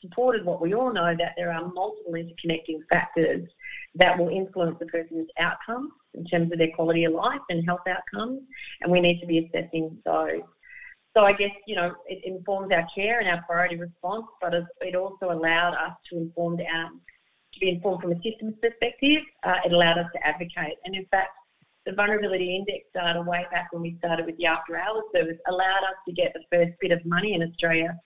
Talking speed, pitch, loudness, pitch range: 205 wpm, 175 Hz, -26 LUFS, 170-195 Hz